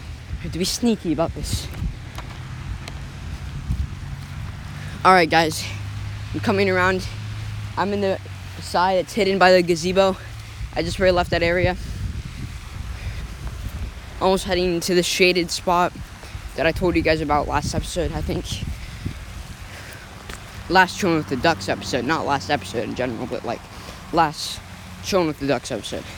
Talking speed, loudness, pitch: 140 wpm, -22 LUFS, 145 Hz